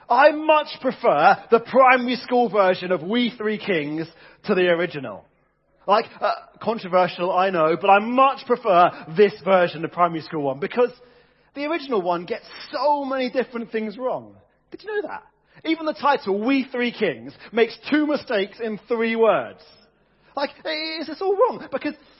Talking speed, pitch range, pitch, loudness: 165 wpm, 190-275 Hz, 235 Hz, -21 LUFS